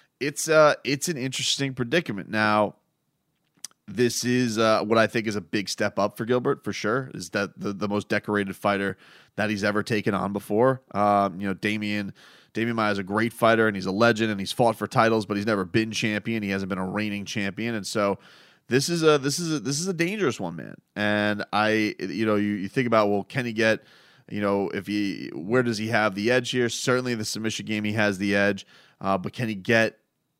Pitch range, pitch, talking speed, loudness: 105-120 Hz, 110 Hz, 225 wpm, -25 LUFS